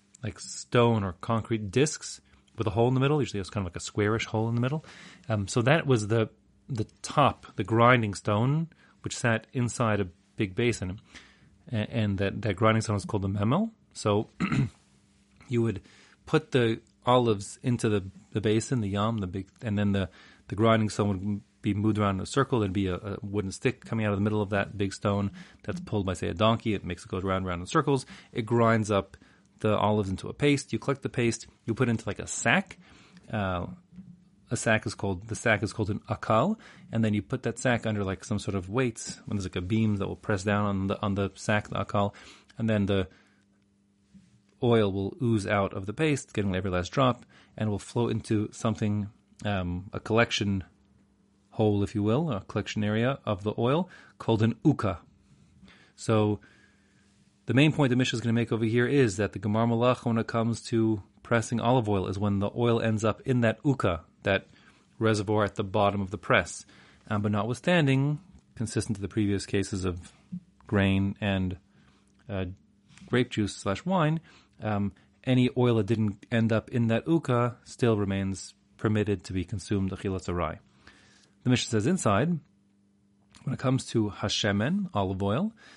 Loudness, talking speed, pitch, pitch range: -28 LUFS, 200 wpm, 110 Hz, 100-120 Hz